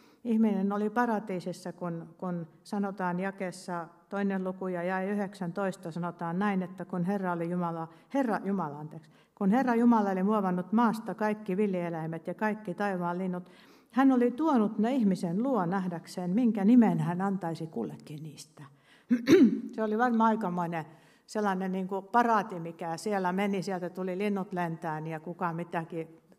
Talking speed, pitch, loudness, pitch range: 150 wpm, 185 Hz, -30 LUFS, 175-210 Hz